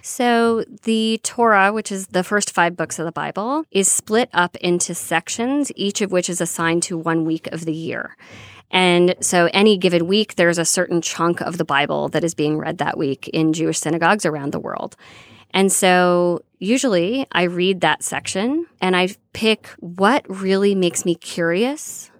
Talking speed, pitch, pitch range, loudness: 180 wpm, 180 Hz, 165-200 Hz, -19 LUFS